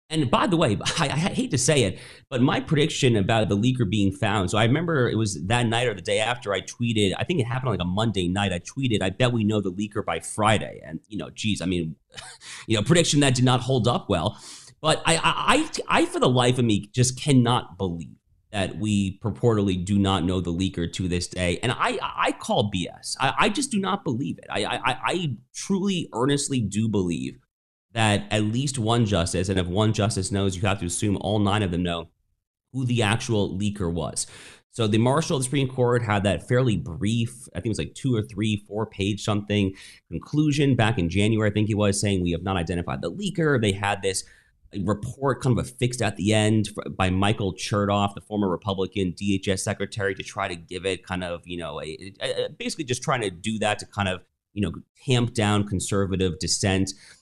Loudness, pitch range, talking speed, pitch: -24 LUFS, 95-120 Hz, 225 wpm, 105 Hz